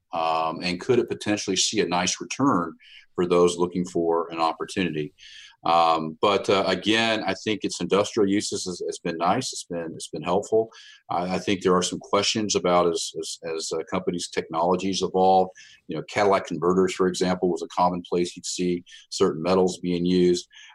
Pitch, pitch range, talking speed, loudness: 90 Hz, 90-105 Hz, 180 wpm, -24 LUFS